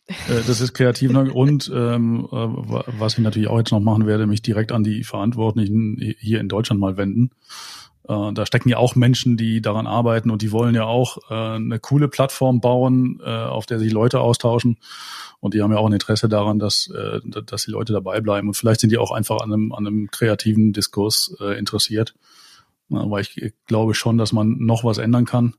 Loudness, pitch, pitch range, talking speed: -19 LUFS, 110 Hz, 110-120 Hz, 205 wpm